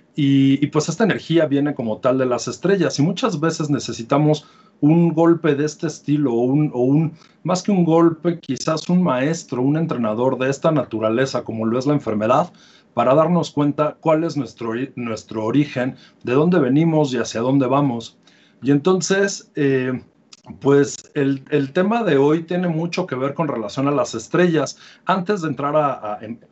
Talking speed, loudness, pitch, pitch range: 180 wpm, -19 LUFS, 145 Hz, 130-165 Hz